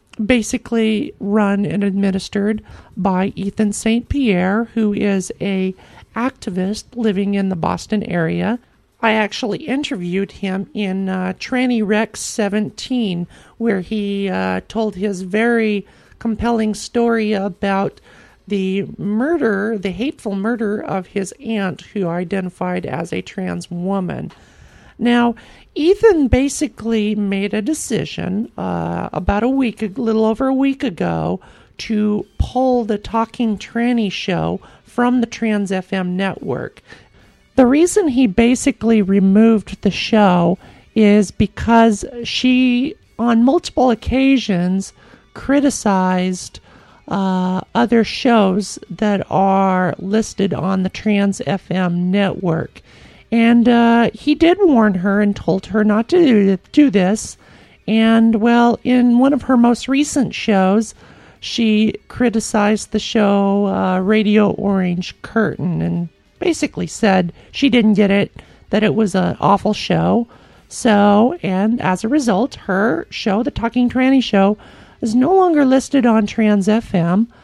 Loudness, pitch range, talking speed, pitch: -17 LUFS, 195-235 Hz, 125 wpm, 215 Hz